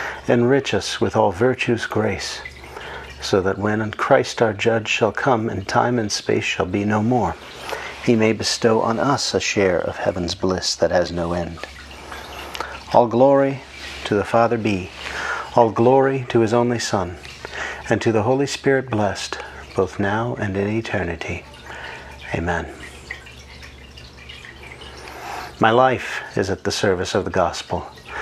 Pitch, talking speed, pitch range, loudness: 110 Hz, 145 wpm, 85-120 Hz, -20 LUFS